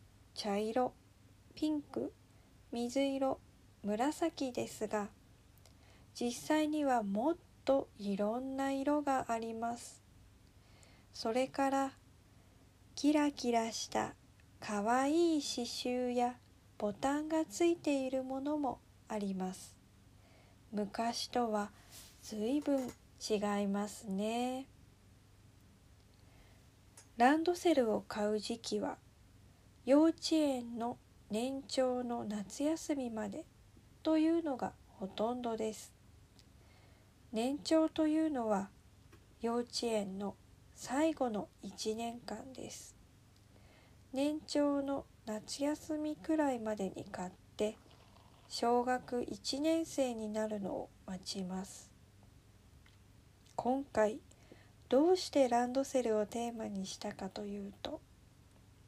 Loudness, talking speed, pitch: -36 LUFS, 180 characters per minute, 220 Hz